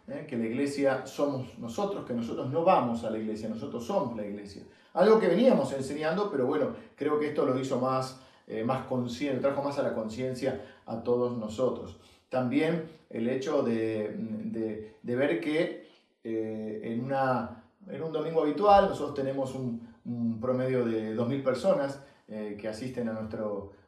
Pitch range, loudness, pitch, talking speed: 115-140 Hz, -30 LUFS, 130 Hz, 170 wpm